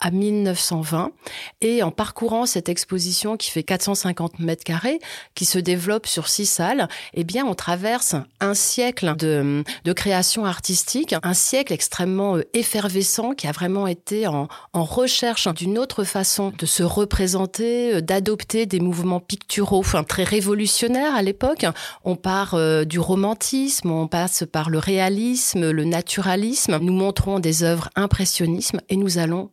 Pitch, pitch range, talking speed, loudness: 190 Hz, 175-215 Hz, 150 wpm, -21 LUFS